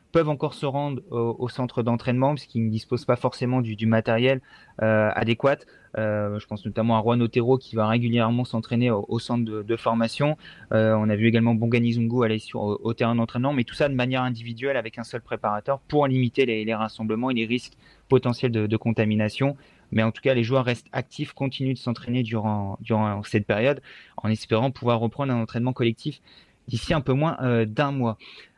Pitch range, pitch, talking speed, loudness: 110-130 Hz, 120 Hz, 210 wpm, -24 LUFS